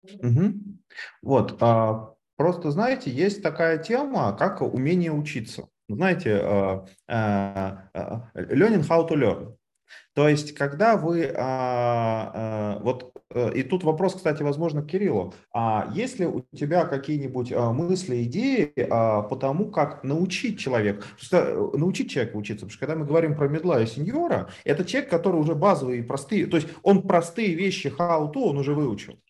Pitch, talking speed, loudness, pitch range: 150 Hz, 150 wpm, -24 LUFS, 120-180 Hz